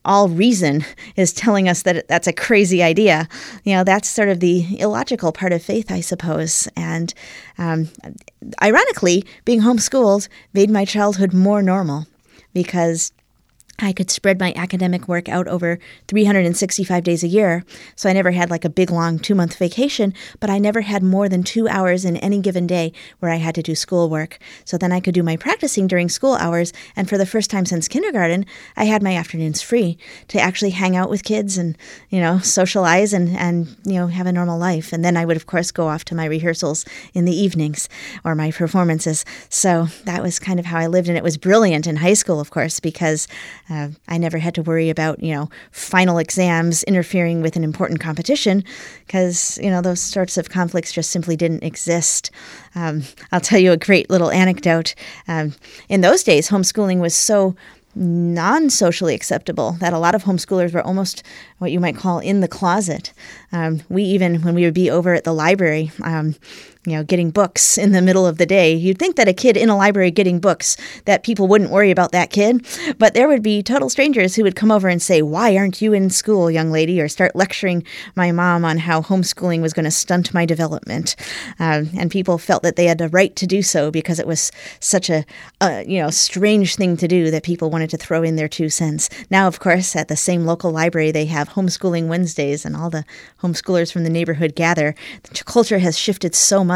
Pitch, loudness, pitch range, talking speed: 180 Hz, -17 LUFS, 165-195 Hz, 215 wpm